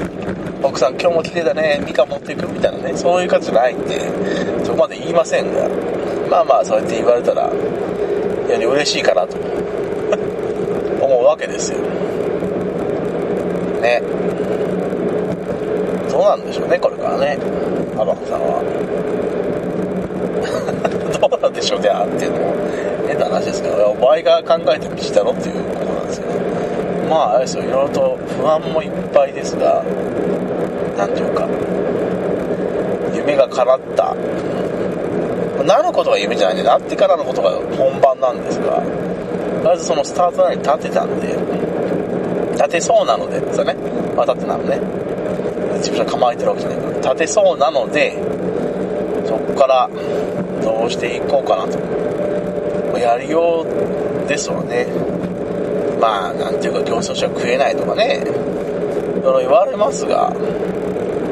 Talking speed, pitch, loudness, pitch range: 305 characters per minute, 165 Hz, -17 LUFS, 135-180 Hz